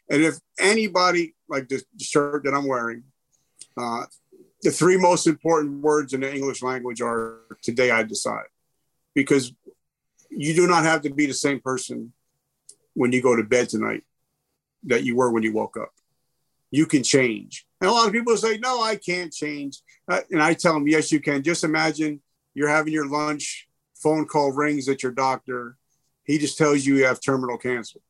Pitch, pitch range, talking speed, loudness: 145 Hz, 130-155 Hz, 185 wpm, -22 LUFS